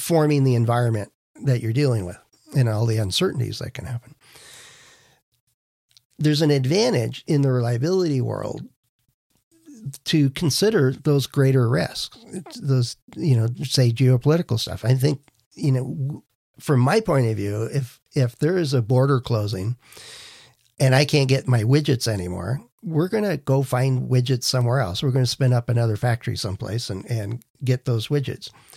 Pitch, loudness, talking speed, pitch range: 130 Hz, -22 LUFS, 160 wpm, 120-145 Hz